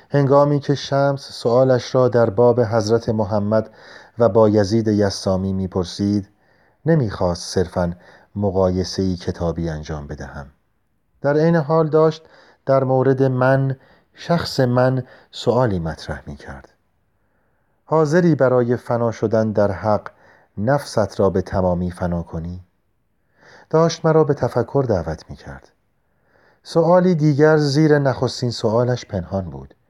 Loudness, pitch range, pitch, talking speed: -18 LUFS, 95-135 Hz, 115 Hz, 120 wpm